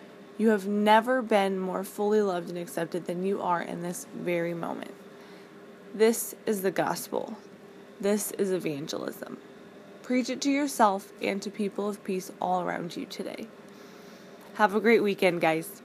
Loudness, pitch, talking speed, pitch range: -28 LUFS, 205 Hz, 155 wpm, 185-215 Hz